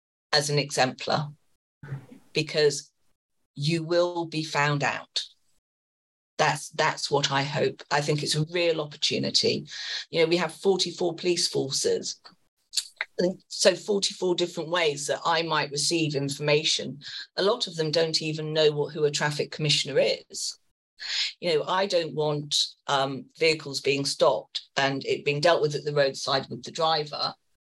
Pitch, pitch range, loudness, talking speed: 155 Hz, 145-170 Hz, -26 LUFS, 155 wpm